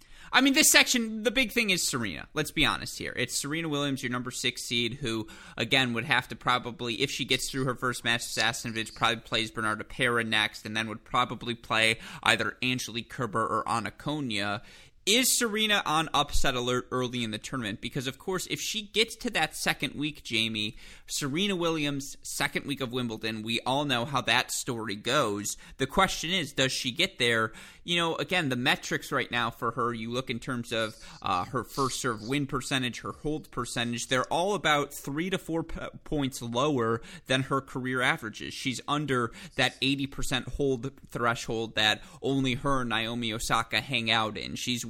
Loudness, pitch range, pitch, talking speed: -28 LUFS, 115-145 Hz, 125 Hz, 190 wpm